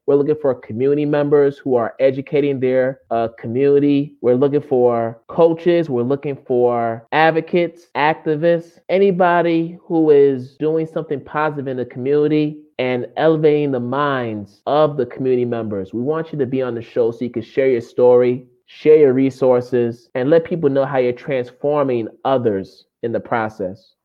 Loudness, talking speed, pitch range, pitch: -17 LUFS, 160 wpm, 125-150 Hz, 140 Hz